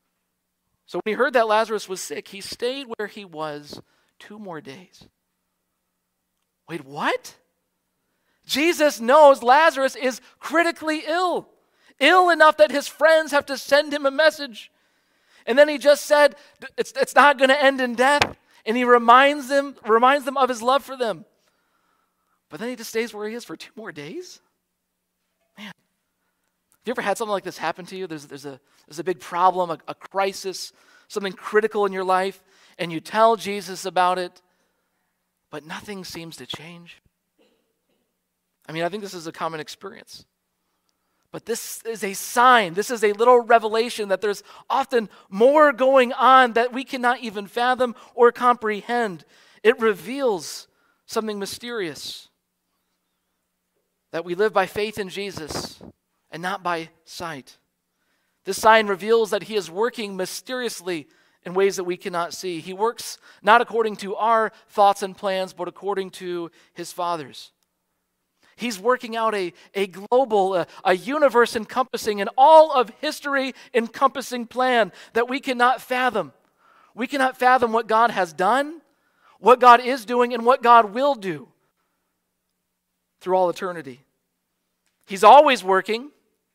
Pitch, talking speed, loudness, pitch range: 225 Hz, 155 wpm, -20 LUFS, 190-260 Hz